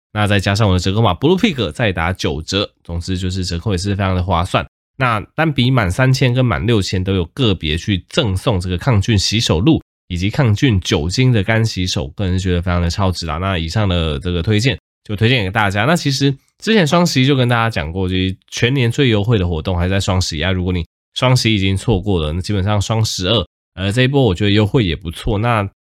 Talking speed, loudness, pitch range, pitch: 355 characters per minute, -16 LUFS, 90-115 Hz, 100 Hz